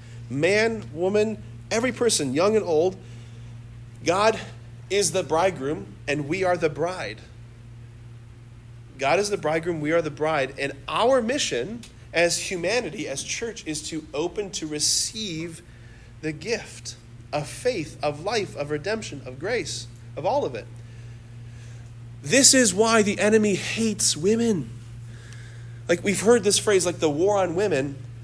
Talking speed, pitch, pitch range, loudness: 140 wpm, 140 Hz, 115-185 Hz, -23 LUFS